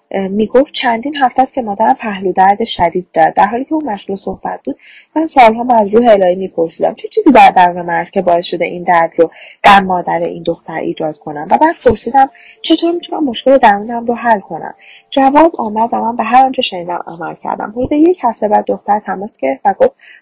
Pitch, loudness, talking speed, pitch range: 225 Hz, -12 LUFS, 215 wpm, 180-270 Hz